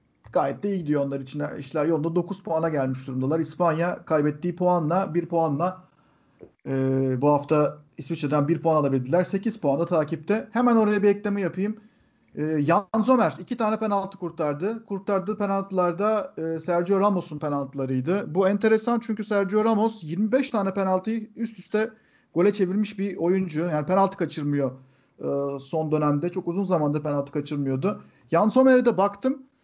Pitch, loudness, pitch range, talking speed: 175 Hz, -25 LUFS, 150-205 Hz, 145 wpm